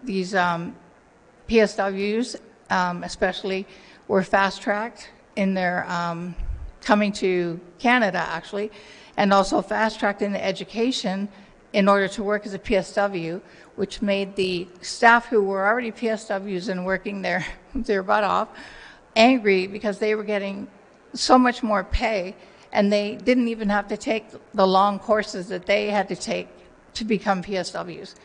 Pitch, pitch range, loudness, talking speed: 200 Hz, 190-215 Hz, -23 LUFS, 150 wpm